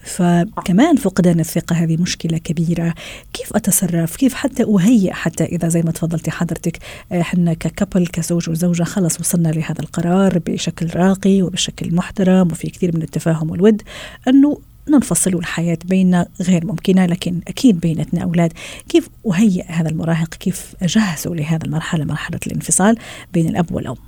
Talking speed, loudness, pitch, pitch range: 140 wpm, -17 LUFS, 175 Hz, 165-190 Hz